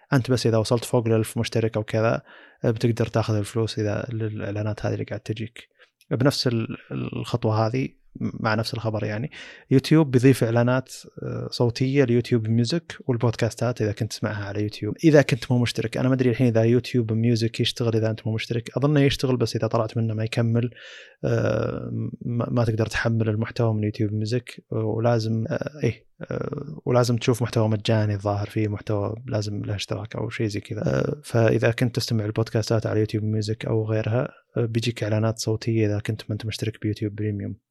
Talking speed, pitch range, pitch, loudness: 165 wpm, 110-125 Hz, 115 Hz, -24 LUFS